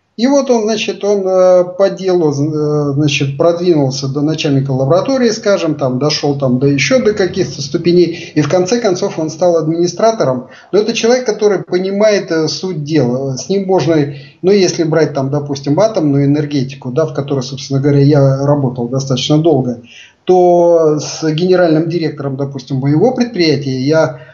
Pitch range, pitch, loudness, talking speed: 140-180 Hz, 155 Hz, -13 LUFS, 155 wpm